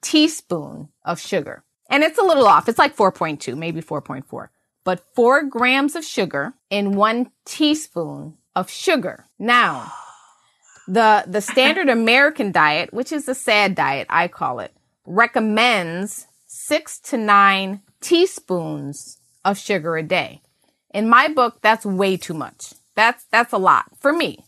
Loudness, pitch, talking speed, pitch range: -18 LUFS, 215 Hz, 145 wpm, 180-260 Hz